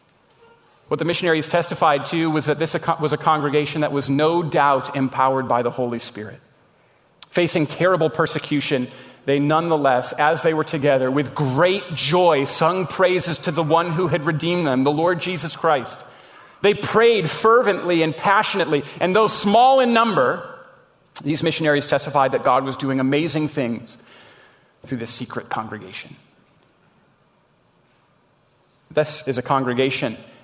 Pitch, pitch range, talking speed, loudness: 155 Hz, 135-170 Hz, 140 wpm, -19 LUFS